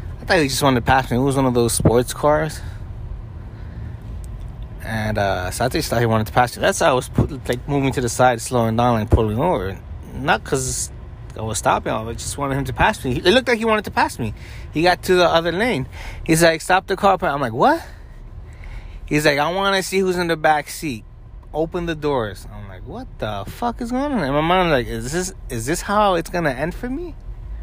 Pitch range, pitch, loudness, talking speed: 110-165 Hz, 125 Hz, -19 LUFS, 240 wpm